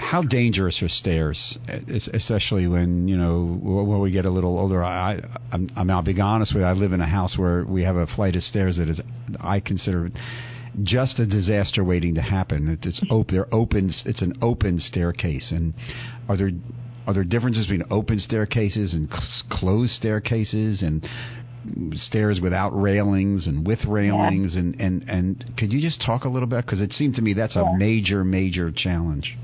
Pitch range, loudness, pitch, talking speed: 90-115 Hz, -23 LUFS, 100 Hz, 185 wpm